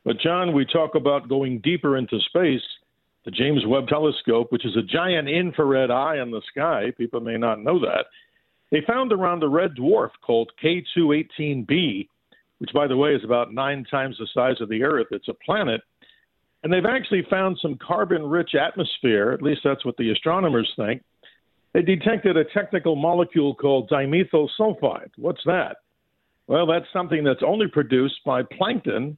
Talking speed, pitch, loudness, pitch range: 175 wpm, 150 Hz, -22 LUFS, 130-175 Hz